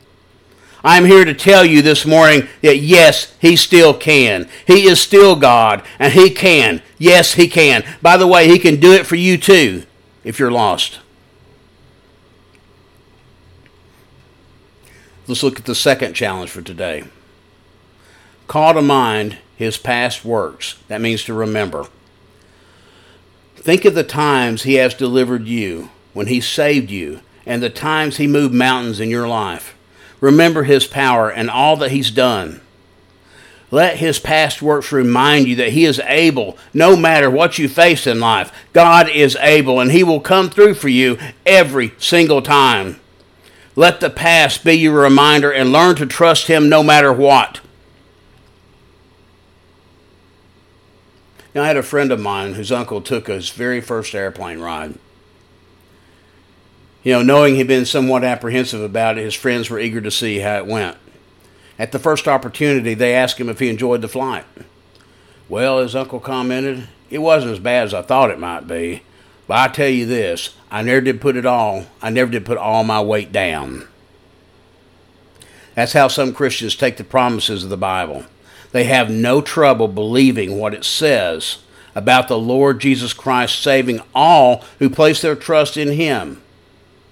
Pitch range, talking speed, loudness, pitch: 105-145 Hz, 160 wpm, -12 LUFS, 125 Hz